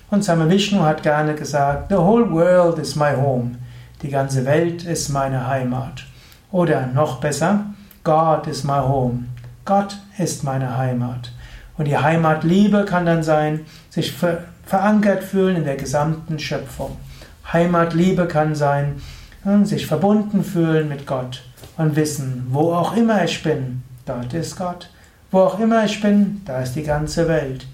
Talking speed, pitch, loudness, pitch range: 150 wpm, 155 Hz, -19 LUFS, 135-175 Hz